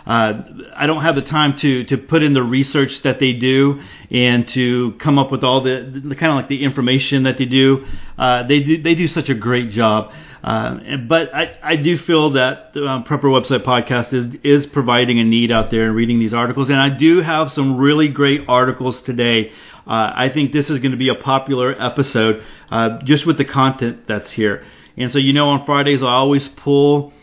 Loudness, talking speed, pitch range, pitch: -16 LUFS, 225 wpm, 125-145 Hz, 135 Hz